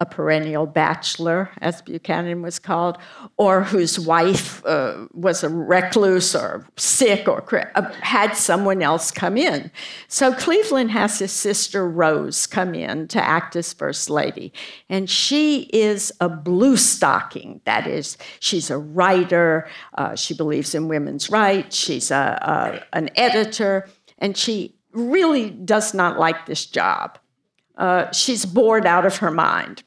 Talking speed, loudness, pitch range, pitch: 150 wpm, -19 LUFS, 165-215 Hz, 185 Hz